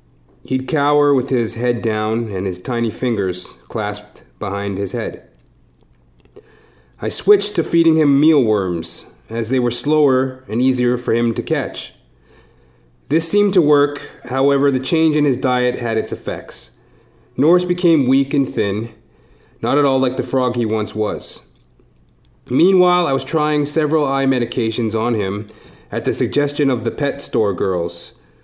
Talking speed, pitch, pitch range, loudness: 155 wpm, 130 Hz, 115-145 Hz, -18 LUFS